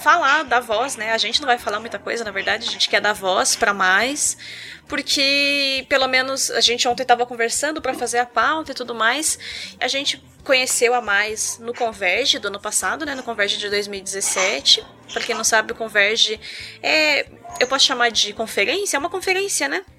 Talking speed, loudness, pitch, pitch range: 200 wpm, -19 LUFS, 240 Hz, 220-275 Hz